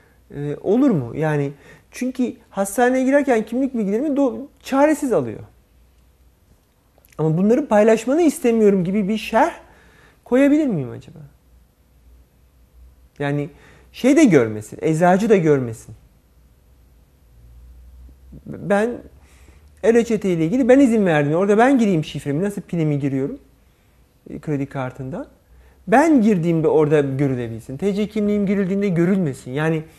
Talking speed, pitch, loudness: 110 wpm, 160 Hz, -18 LUFS